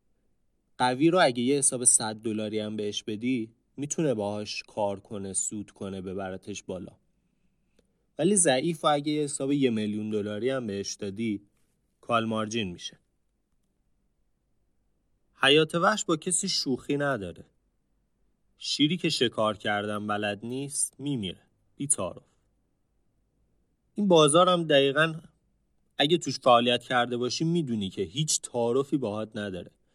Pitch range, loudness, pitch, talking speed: 105-145 Hz, -26 LUFS, 120 Hz, 125 wpm